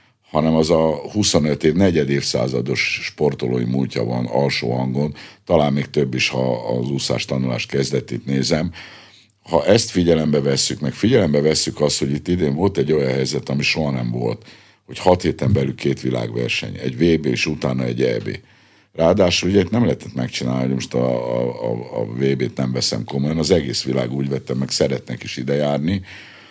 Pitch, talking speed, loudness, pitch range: 70 Hz, 175 wpm, -19 LUFS, 65-80 Hz